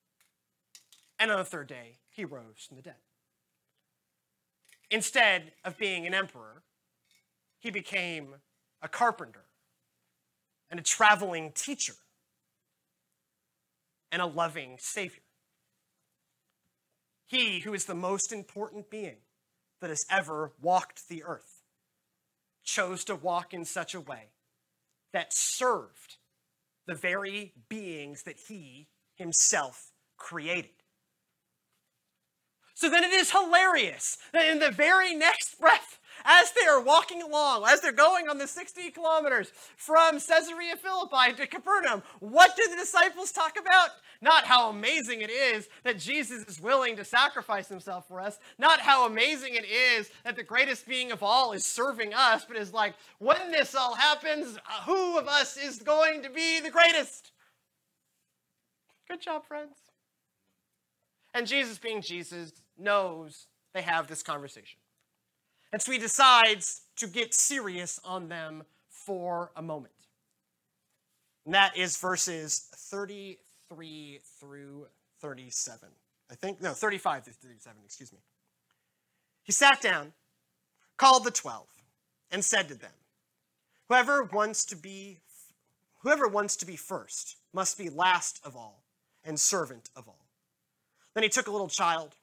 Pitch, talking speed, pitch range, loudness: 205 Hz, 135 wpm, 170-280 Hz, -26 LUFS